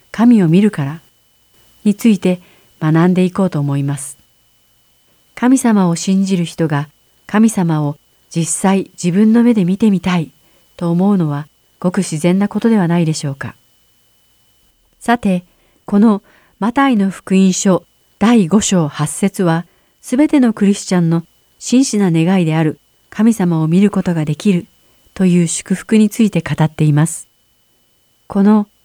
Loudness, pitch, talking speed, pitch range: -14 LUFS, 185 Hz, 260 characters per minute, 160-205 Hz